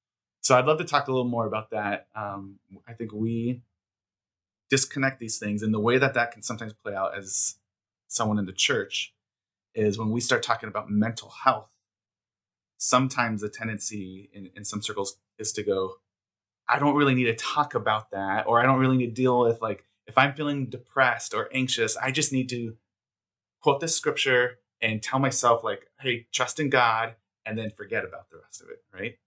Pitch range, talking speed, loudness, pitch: 100-125 Hz, 195 wpm, -26 LUFS, 110 Hz